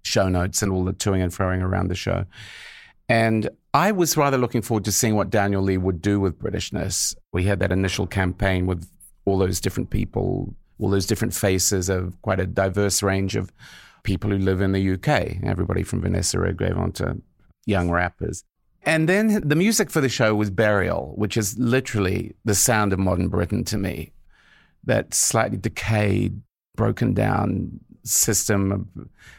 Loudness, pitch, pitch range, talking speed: -22 LUFS, 100 Hz, 95-110 Hz, 175 wpm